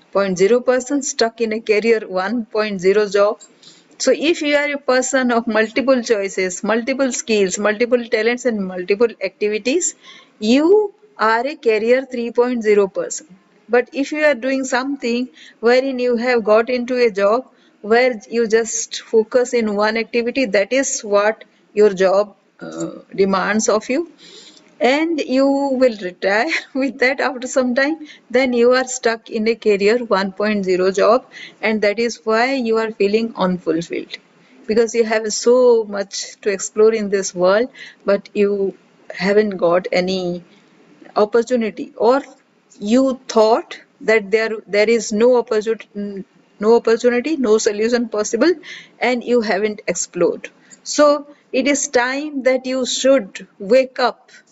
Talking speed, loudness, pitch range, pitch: 140 wpm, -17 LUFS, 210-255 Hz, 230 Hz